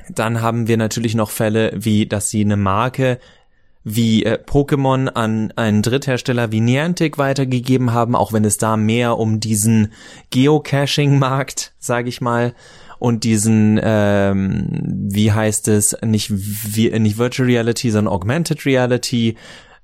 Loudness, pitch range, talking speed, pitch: -17 LUFS, 110-125 Hz, 140 wpm, 115 Hz